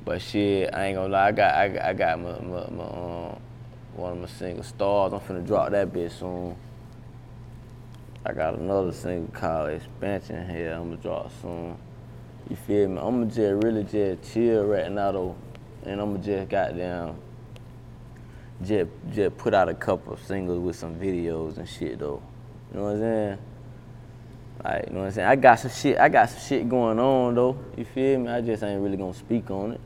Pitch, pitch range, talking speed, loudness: 105 Hz, 90-120 Hz, 200 wpm, -26 LUFS